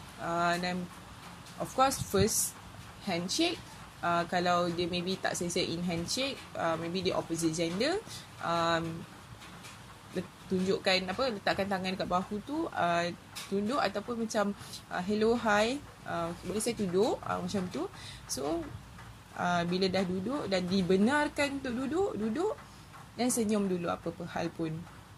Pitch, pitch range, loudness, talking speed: 185 Hz, 170-215 Hz, -32 LUFS, 140 wpm